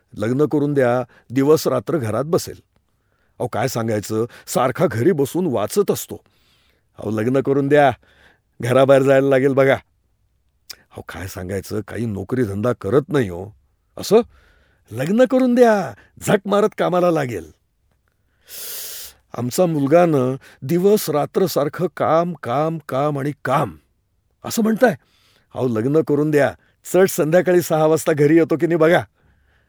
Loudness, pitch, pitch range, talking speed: -18 LUFS, 140 Hz, 110-170 Hz, 135 wpm